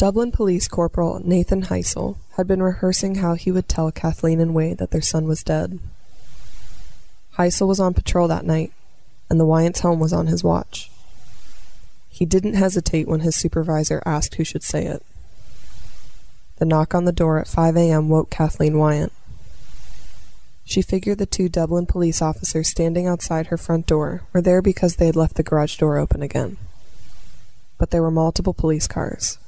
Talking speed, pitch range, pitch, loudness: 175 wpm, 155-180 Hz, 165 Hz, -19 LUFS